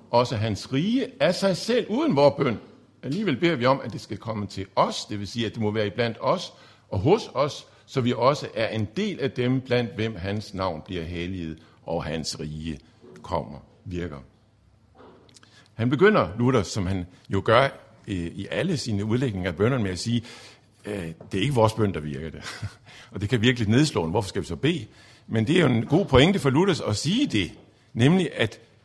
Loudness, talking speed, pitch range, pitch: -25 LUFS, 210 wpm, 100-130 Hz, 110 Hz